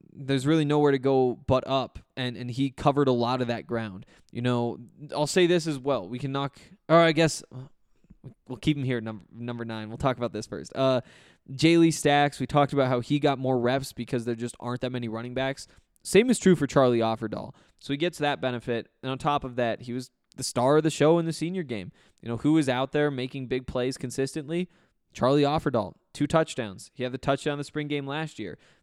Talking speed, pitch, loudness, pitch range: 235 wpm, 135 Hz, -26 LUFS, 120-150 Hz